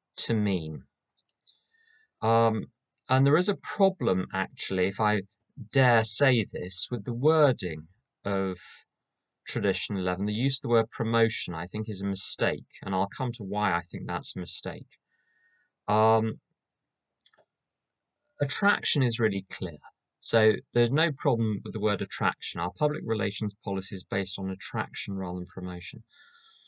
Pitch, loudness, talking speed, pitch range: 110 Hz, -27 LUFS, 145 wpm, 100-130 Hz